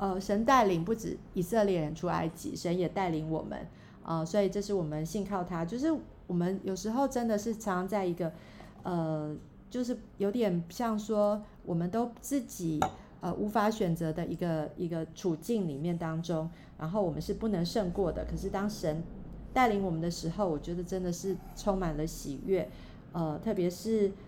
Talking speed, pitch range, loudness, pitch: 265 characters per minute, 165-210 Hz, -33 LUFS, 180 Hz